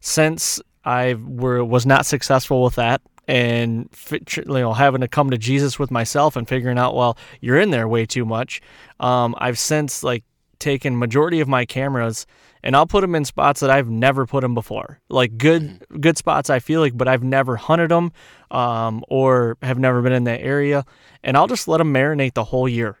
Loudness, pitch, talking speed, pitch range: -19 LUFS, 130 Hz, 205 wpm, 125-145 Hz